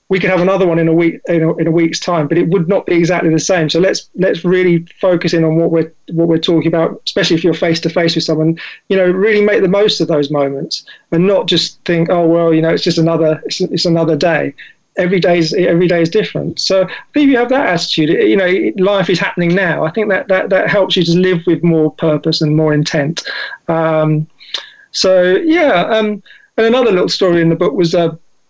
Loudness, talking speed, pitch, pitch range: -13 LUFS, 240 wpm, 170 Hz, 165-190 Hz